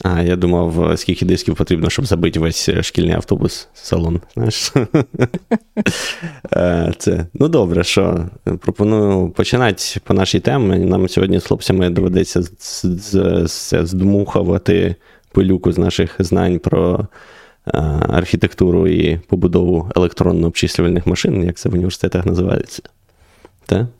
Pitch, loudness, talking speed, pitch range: 90 Hz, -16 LUFS, 100 wpm, 85-105 Hz